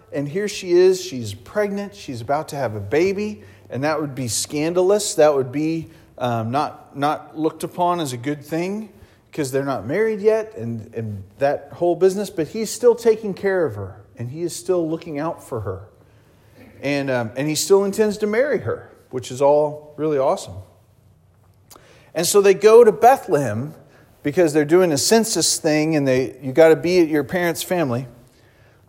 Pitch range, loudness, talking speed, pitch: 130-185 Hz, -19 LUFS, 185 wpm, 150 Hz